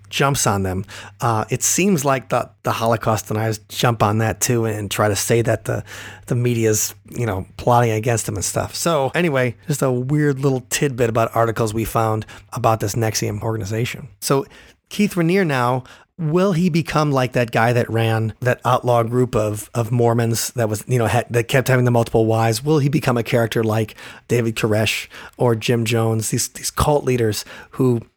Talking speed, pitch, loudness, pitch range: 190 wpm, 115 Hz, -19 LUFS, 110-130 Hz